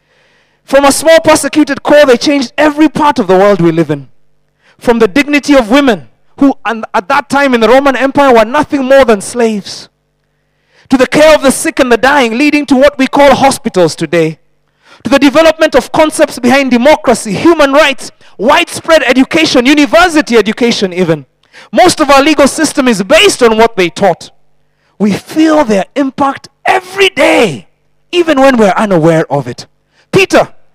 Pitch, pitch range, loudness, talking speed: 270 Hz, 220-300 Hz, -8 LUFS, 170 wpm